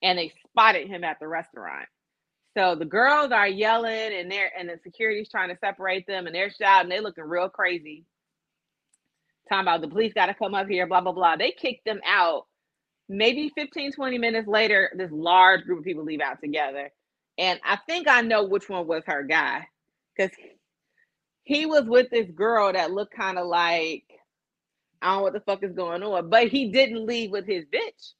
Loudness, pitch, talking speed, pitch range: -23 LUFS, 200 Hz, 200 wpm, 180-230 Hz